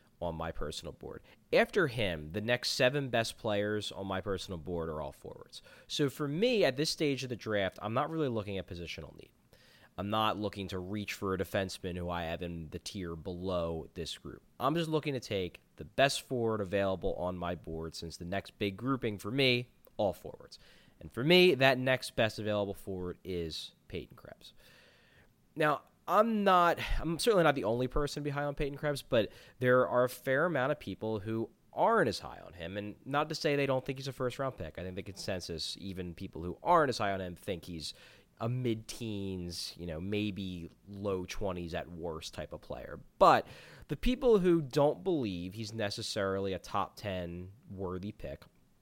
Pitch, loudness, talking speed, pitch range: 105 Hz, -33 LUFS, 200 wpm, 90-130 Hz